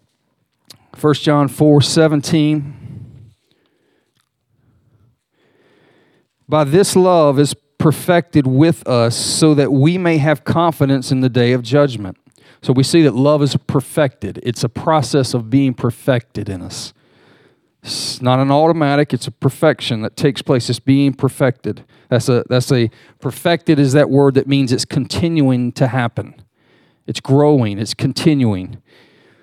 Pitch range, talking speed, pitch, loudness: 125-150 Hz, 140 wpm, 135 Hz, -15 LUFS